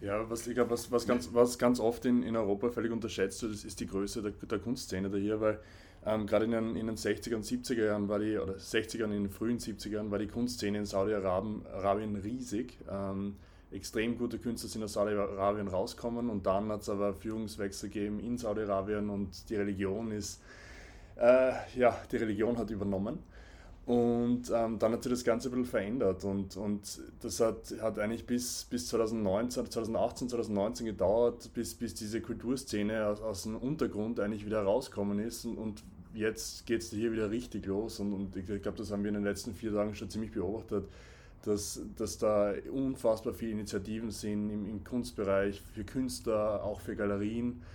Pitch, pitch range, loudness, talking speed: 105 Hz, 100-115 Hz, -34 LUFS, 190 wpm